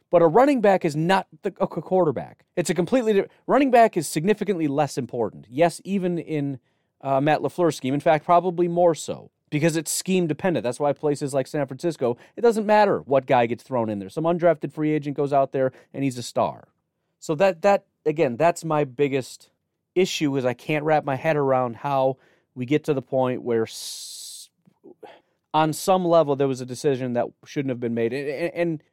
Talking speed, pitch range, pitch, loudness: 205 wpm, 135-175 Hz, 155 Hz, -23 LUFS